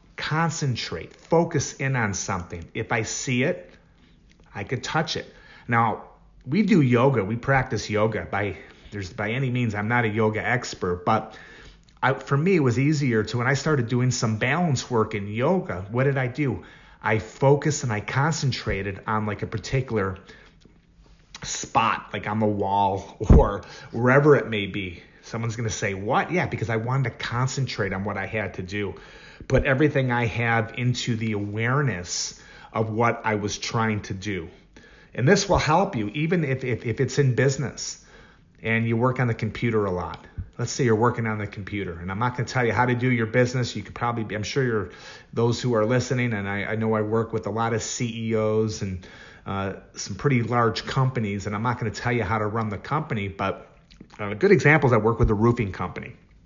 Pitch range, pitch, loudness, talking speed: 105-125 Hz, 115 Hz, -24 LUFS, 205 wpm